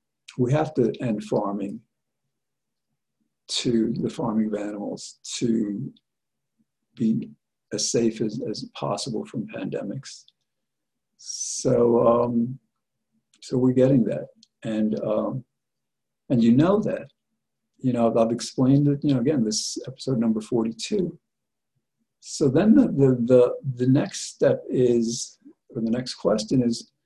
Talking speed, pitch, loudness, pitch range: 130 wpm, 120 Hz, -23 LUFS, 115-130 Hz